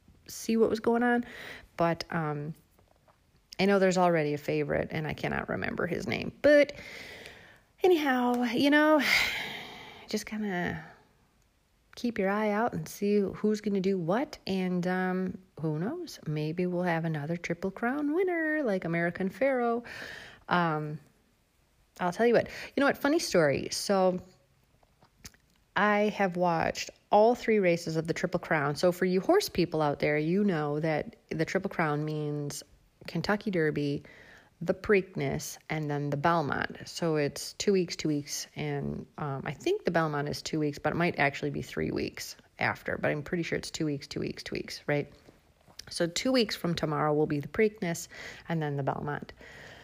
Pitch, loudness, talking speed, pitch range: 180 Hz, -29 LUFS, 170 wpm, 155-210 Hz